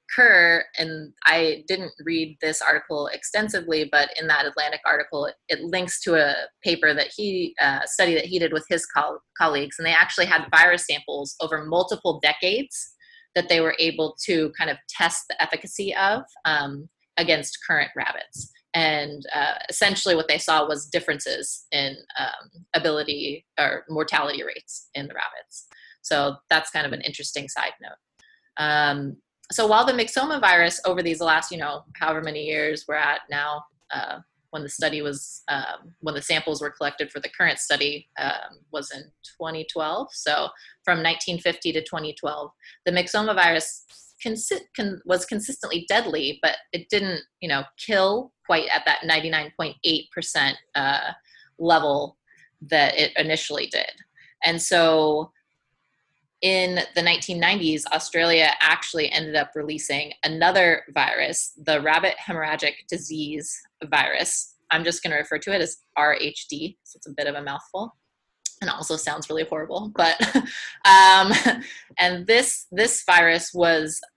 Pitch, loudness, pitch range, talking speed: 165 Hz, -22 LUFS, 150-185 Hz, 155 wpm